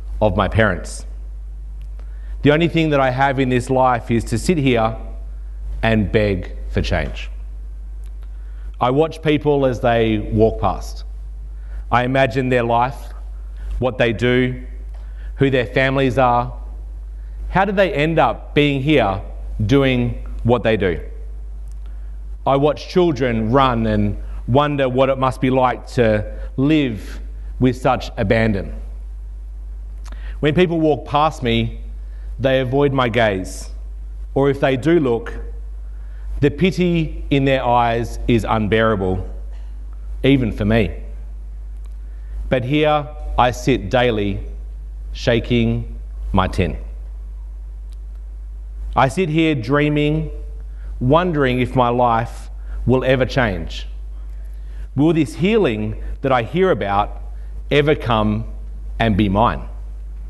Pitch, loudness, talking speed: 110 Hz, -18 LUFS, 120 wpm